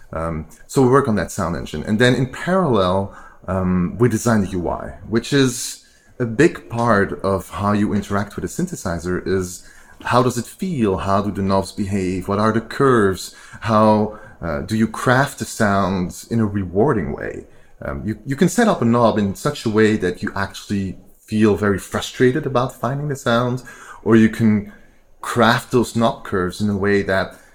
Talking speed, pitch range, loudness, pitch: 190 wpm, 95-120 Hz, -19 LUFS, 105 Hz